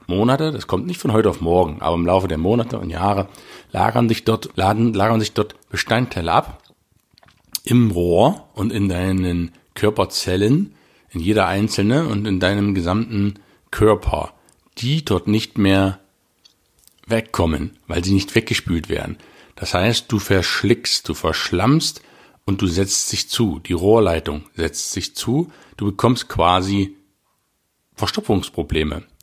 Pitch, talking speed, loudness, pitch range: 100 Hz, 140 wpm, -19 LUFS, 90-110 Hz